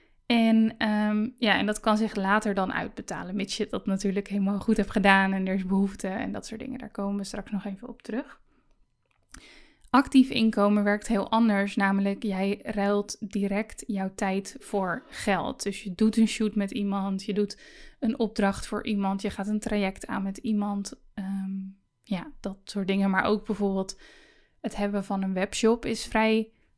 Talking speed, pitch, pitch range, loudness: 185 wpm, 205 Hz, 195-225 Hz, -27 LUFS